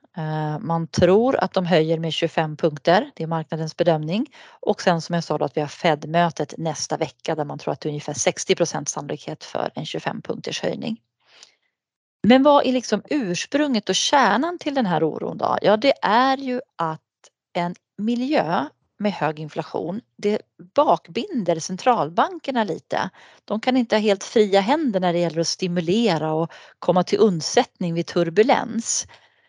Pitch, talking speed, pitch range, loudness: 185 Hz, 165 wpm, 165-235 Hz, -22 LUFS